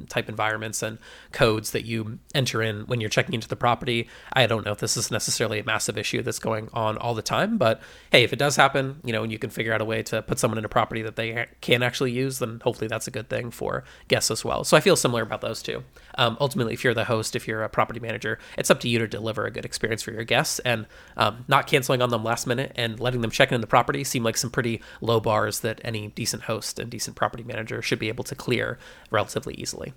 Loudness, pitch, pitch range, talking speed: -25 LUFS, 115 Hz, 110-125 Hz, 265 wpm